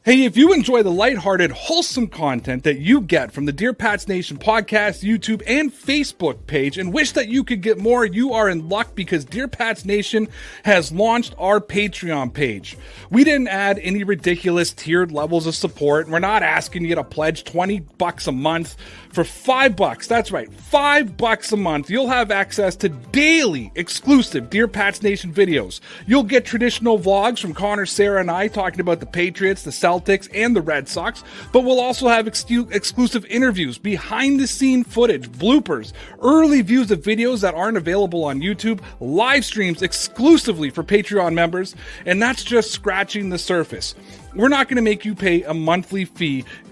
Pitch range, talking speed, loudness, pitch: 175-240 Hz, 180 wpm, -18 LUFS, 205 Hz